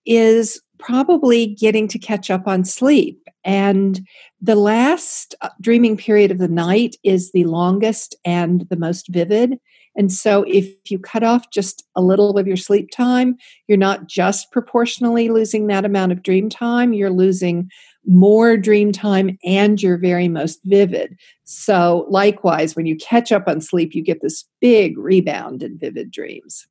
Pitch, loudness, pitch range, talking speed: 200 Hz, -16 LUFS, 185-225 Hz, 160 wpm